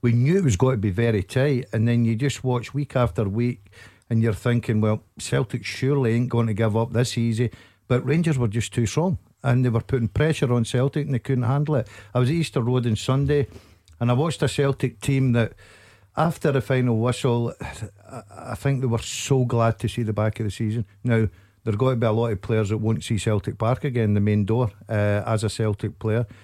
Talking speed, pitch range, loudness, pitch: 230 wpm, 110-130 Hz, -23 LUFS, 120 Hz